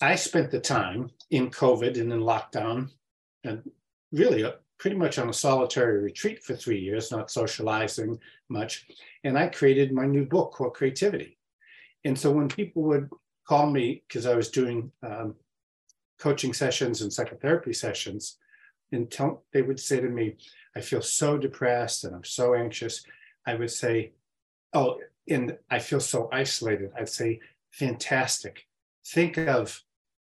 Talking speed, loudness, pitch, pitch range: 150 wpm, -27 LUFS, 130 Hz, 115-145 Hz